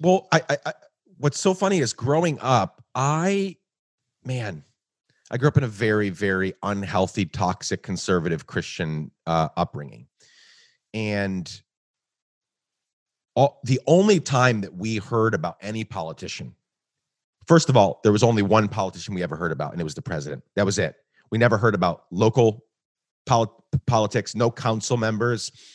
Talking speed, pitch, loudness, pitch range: 155 wpm, 115 Hz, -23 LUFS, 100-135 Hz